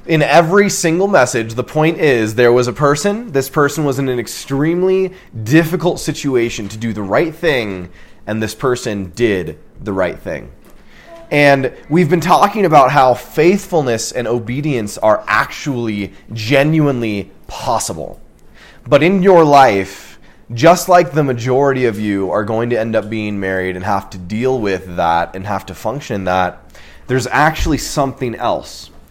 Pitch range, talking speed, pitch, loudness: 105-155 Hz, 155 wpm, 125 Hz, -14 LUFS